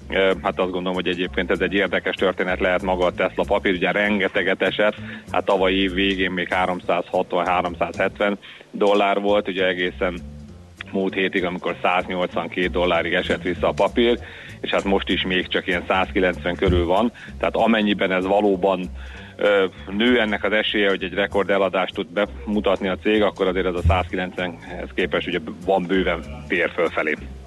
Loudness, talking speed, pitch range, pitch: -21 LUFS, 160 wpm, 90-100 Hz, 95 Hz